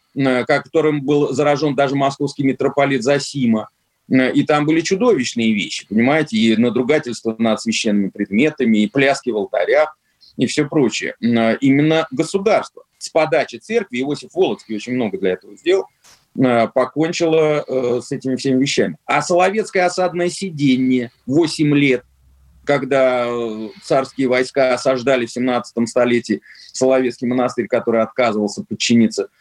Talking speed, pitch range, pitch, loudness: 120 wpm, 120-150 Hz, 130 Hz, -17 LUFS